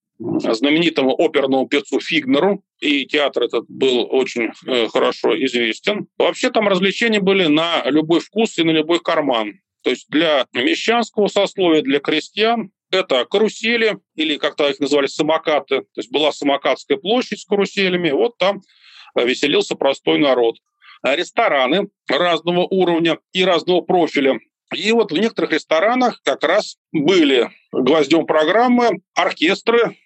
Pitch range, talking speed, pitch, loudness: 155-235 Hz, 130 wpm, 185 Hz, -17 LUFS